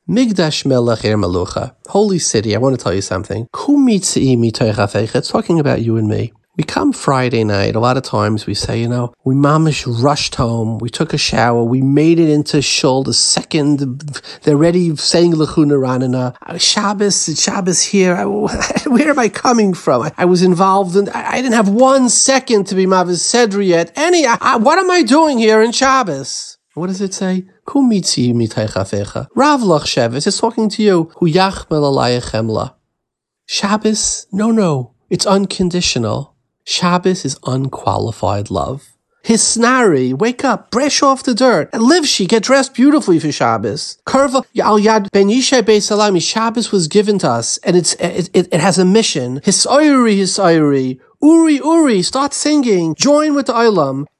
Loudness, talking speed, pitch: -13 LUFS, 155 wpm, 180 Hz